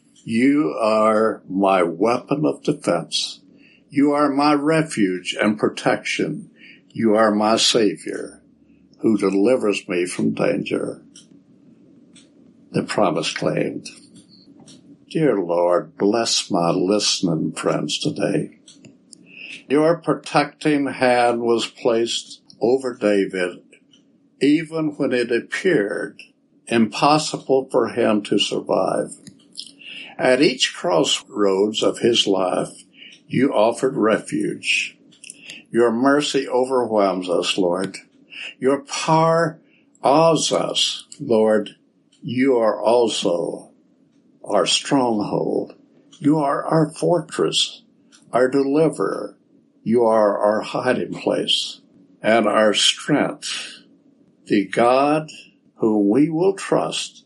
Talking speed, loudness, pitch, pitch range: 95 wpm, -19 LUFS, 125 Hz, 105-150 Hz